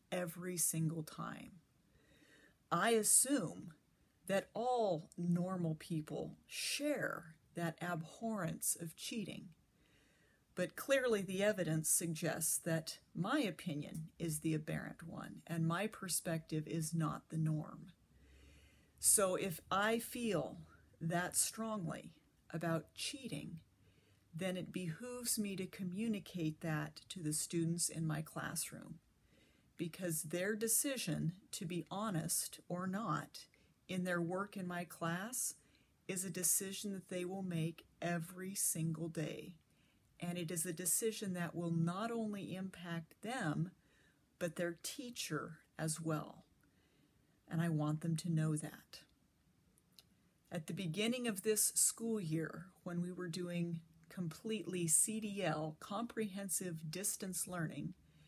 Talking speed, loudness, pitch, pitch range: 120 wpm, -39 LUFS, 175 Hz, 160-195 Hz